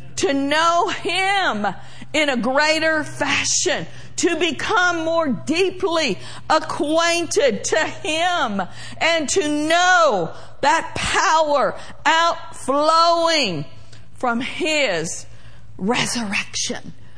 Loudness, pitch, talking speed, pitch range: -19 LUFS, 320 Hz, 80 wpm, 260-340 Hz